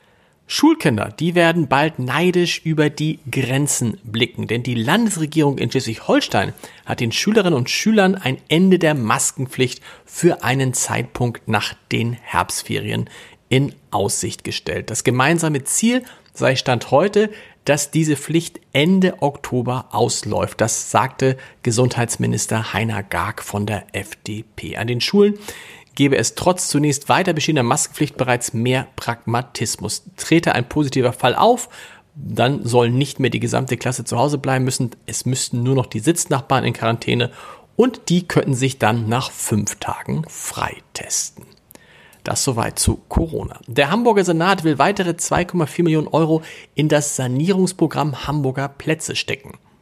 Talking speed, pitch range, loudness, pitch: 140 wpm, 120-160 Hz, -19 LUFS, 135 Hz